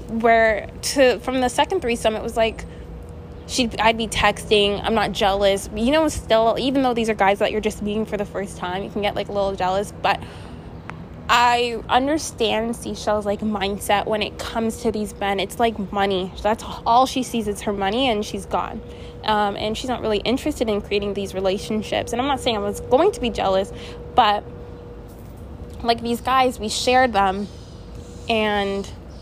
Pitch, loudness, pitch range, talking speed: 215 Hz, -21 LUFS, 200-235 Hz, 190 wpm